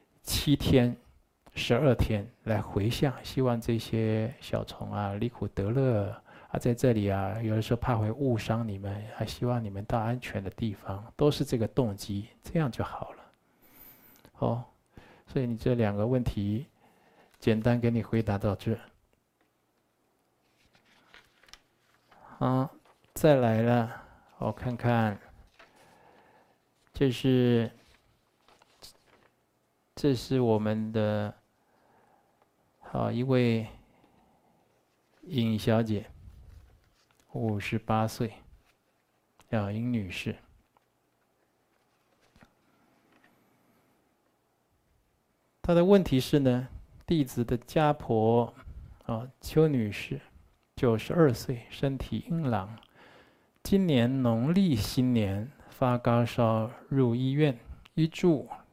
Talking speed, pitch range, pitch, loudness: 140 characters per minute, 110-130 Hz, 115 Hz, -29 LUFS